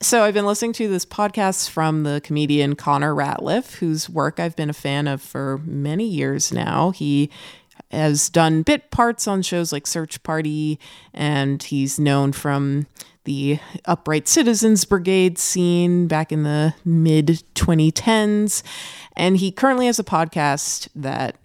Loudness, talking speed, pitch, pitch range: -20 LUFS, 150 wpm, 160 Hz, 145-185 Hz